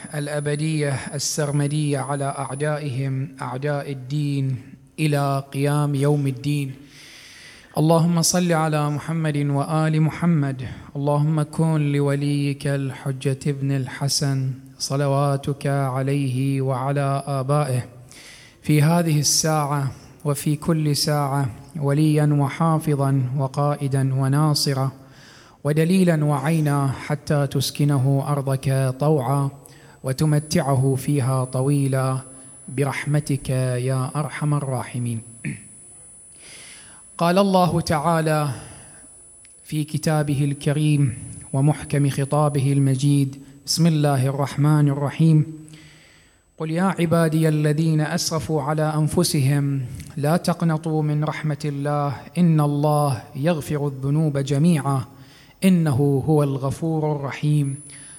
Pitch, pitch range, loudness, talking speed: 145 Hz, 135-150 Hz, -21 LUFS, 85 wpm